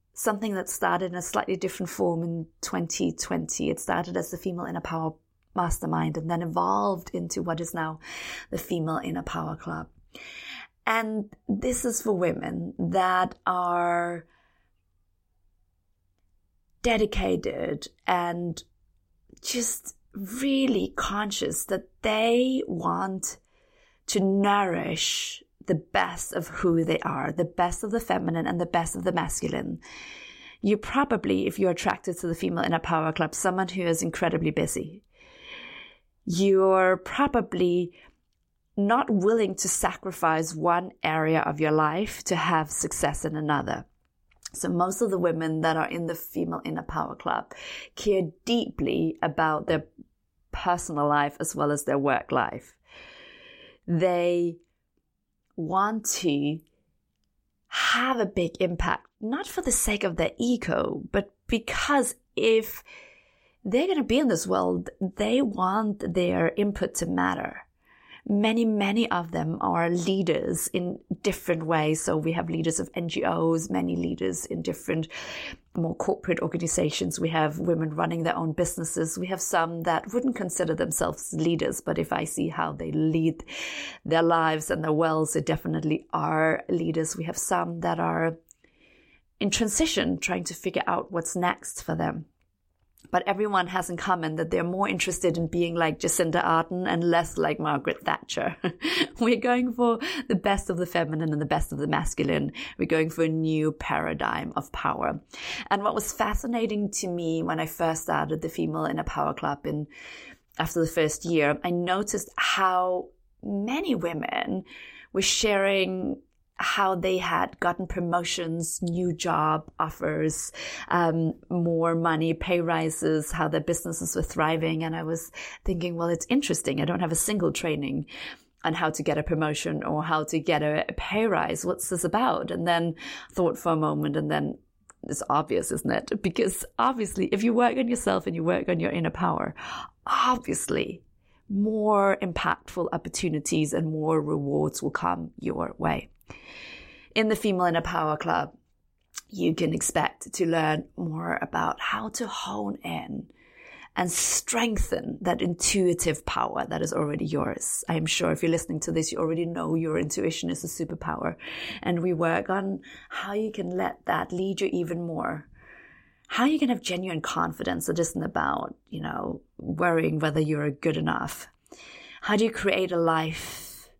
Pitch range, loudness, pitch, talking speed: 160-200 Hz, -27 LUFS, 175 Hz, 155 wpm